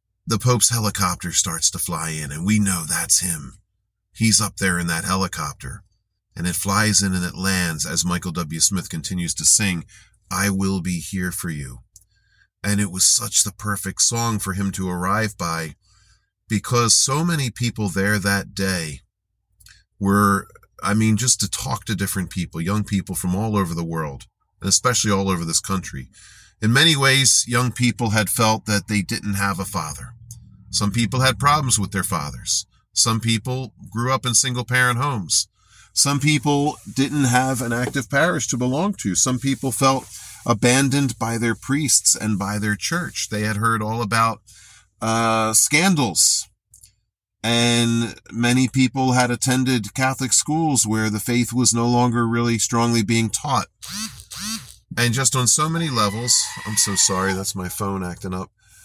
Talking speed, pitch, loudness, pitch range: 170 wpm, 110 Hz, -20 LUFS, 95-120 Hz